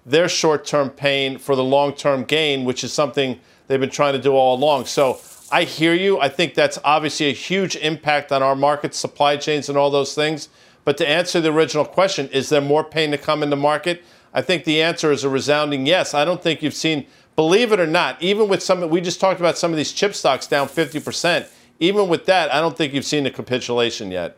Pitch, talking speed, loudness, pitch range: 150 Hz, 240 wpm, -19 LUFS, 140-165 Hz